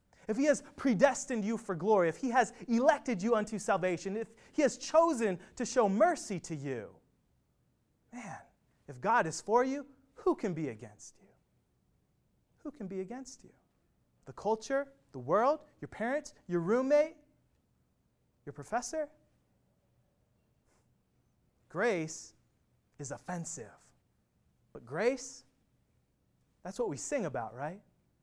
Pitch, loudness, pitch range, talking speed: 230 Hz, -33 LUFS, 180-275 Hz, 130 wpm